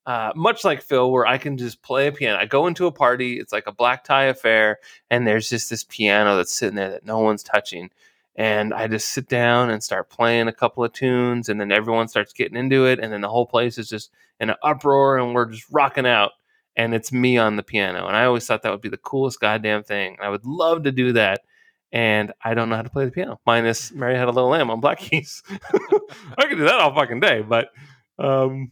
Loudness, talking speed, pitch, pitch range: -20 LUFS, 245 wpm, 120 Hz, 110-135 Hz